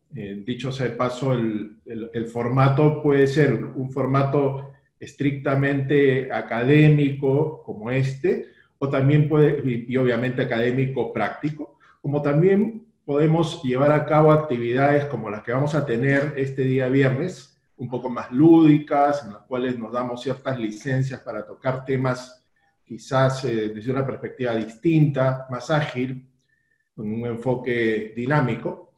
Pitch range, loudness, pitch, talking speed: 125-145 Hz, -22 LUFS, 135 Hz, 140 wpm